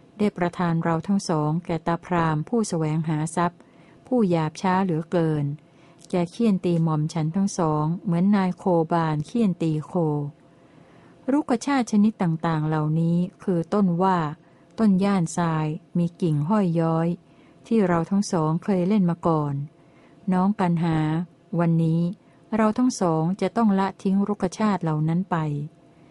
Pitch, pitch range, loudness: 170 Hz, 160-195 Hz, -24 LUFS